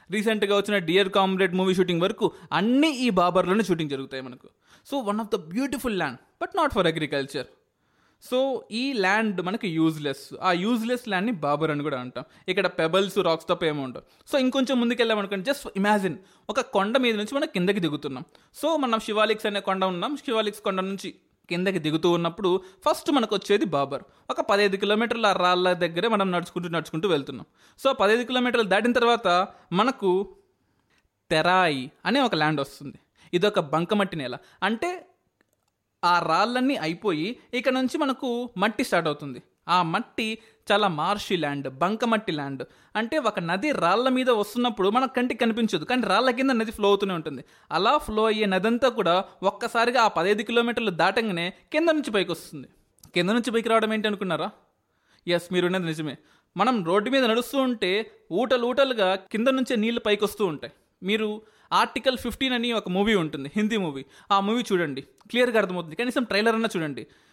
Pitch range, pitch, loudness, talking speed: 180-240 Hz, 205 Hz, -24 LUFS, 165 wpm